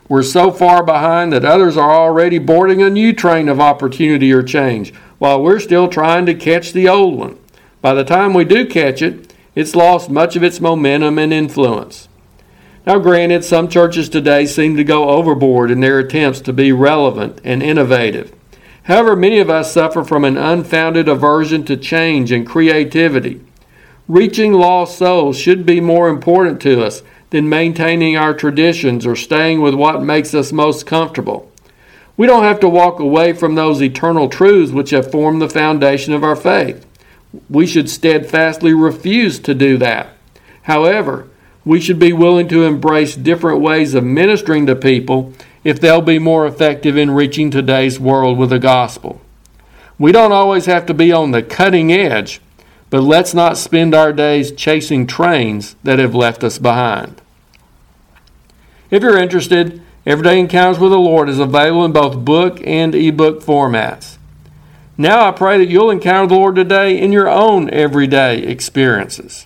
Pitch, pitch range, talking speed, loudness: 155 Hz, 140-175 Hz, 170 wpm, -11 LUFS